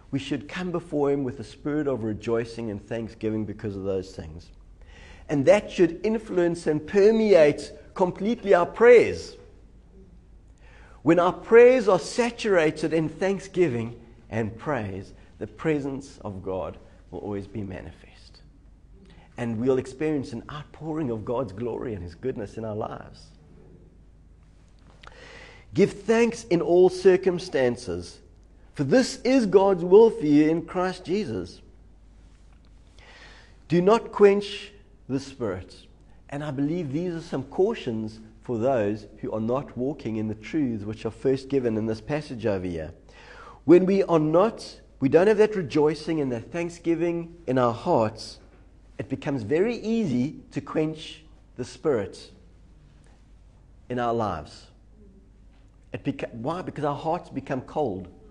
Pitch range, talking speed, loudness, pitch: 100-170 Hz, 140 wpm, -24 LUFS, 130 Hz